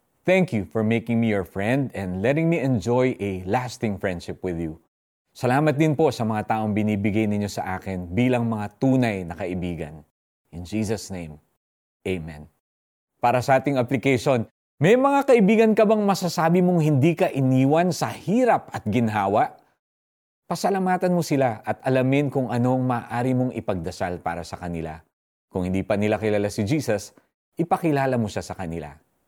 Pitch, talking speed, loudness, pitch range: 115 Hz, 160 wpm, -23 LUFS, 95-135 Hz